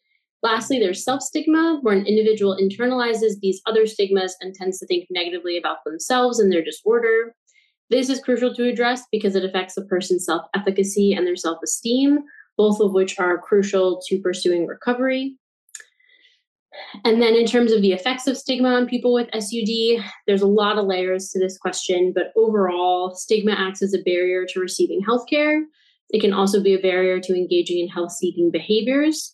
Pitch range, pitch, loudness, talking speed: 185-245 Hz, 205 Hz, -20 LUFS, 175 wpm